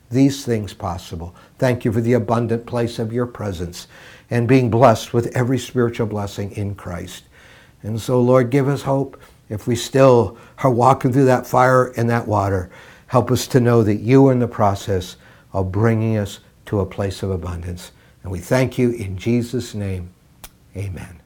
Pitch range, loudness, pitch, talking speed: 100-125 Hz, -18 LUFS, 115 Hz, 180 wpm